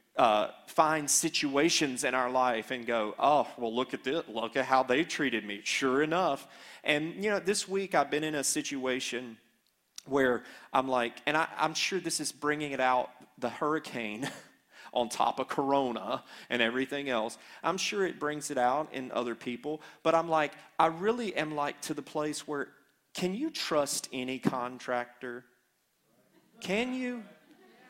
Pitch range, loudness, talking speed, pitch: 125-160 Hz, -31 LUFS, 170 wpm, 145 Hz